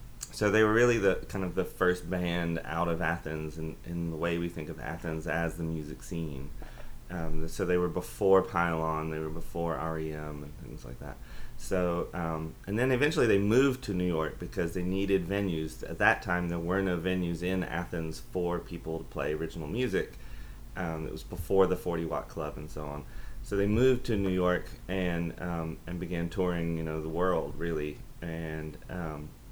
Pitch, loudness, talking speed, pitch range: 85 Hz, -31 LUFS, 195 wpm, 80-90 Hz